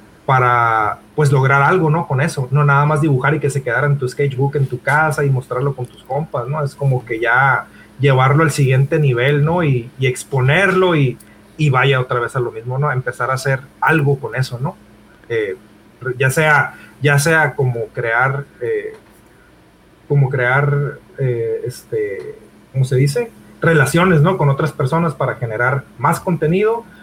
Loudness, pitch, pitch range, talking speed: -16 LUFS, 140 Hz, 130-155 Hz, 175 wpm